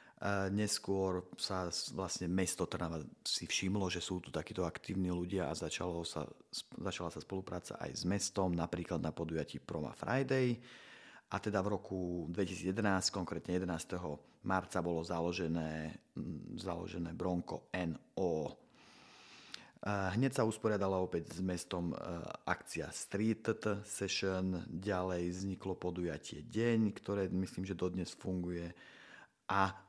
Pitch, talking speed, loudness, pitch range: 95 Hz, 120 wpm, -39 LUFS, 85-100 Hz